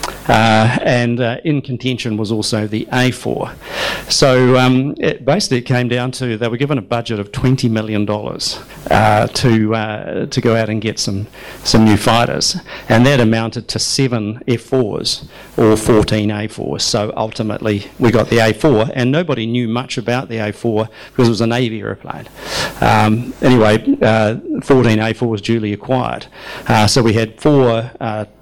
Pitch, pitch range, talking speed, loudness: 115 Hz, 110-125 Hz, 165 wpm, -15 LUFS